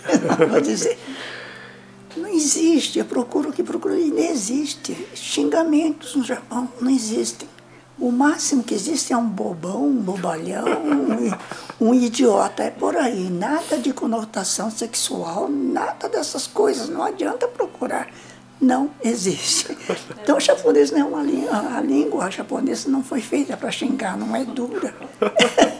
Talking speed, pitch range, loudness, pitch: 145 wpm, 245-315 Hz, -21 LUFS, 280 Hz